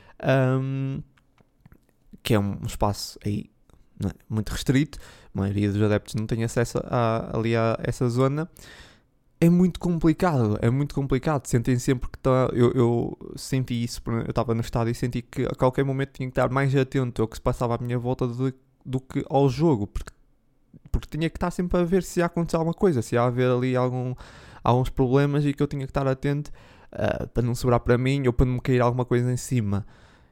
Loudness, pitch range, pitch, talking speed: -25 LUFS, 115-140 Hz, 125 Hz, 210 wpm